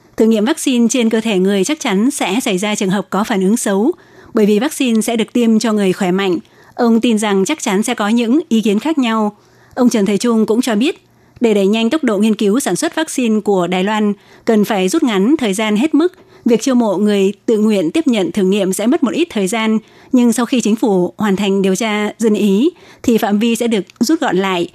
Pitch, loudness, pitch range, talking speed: 220 Hz, -14 LUFS, 200-245 Hz, 250 wpm